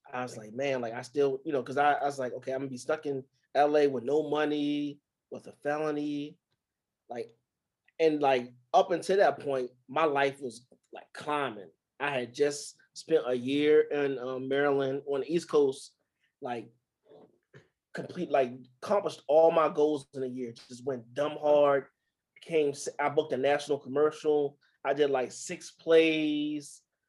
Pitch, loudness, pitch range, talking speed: 145 Hz, -29 LUFS, 130-150 Hz, 170 wpm